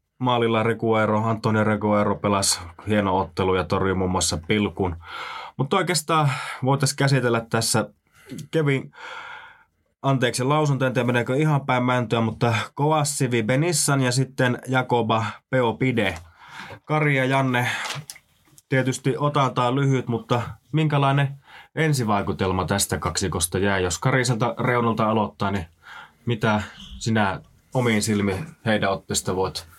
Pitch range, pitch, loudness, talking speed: 100-135 Hz, 120 Hz, -22 LUFS, 115 wpm